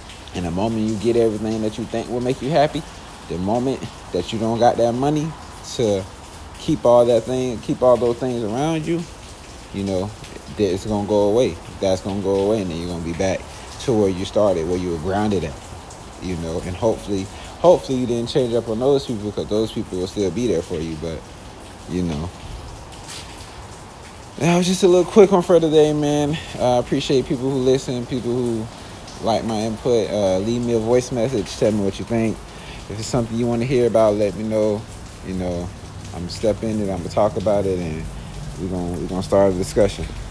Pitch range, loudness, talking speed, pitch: 95-120 Hz, -20 LUFS, 215 wpm, 110 Hz